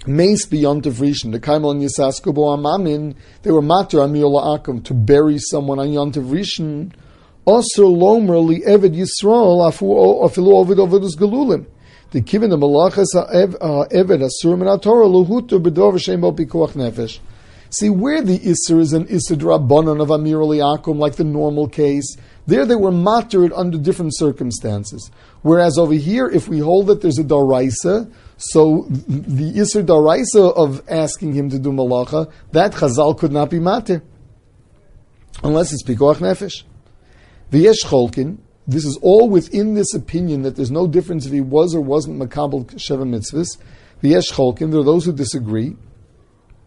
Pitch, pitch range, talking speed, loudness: 155 Hz, 140-180 Hz, 130 wpm, -15 LUFS